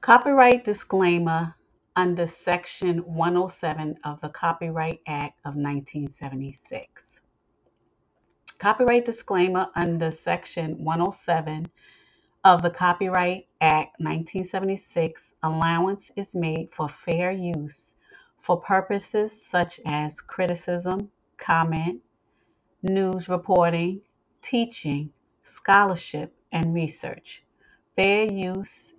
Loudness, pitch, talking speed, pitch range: -24 LUFS, 175 Hz, 85 wpm, 160-195 Hz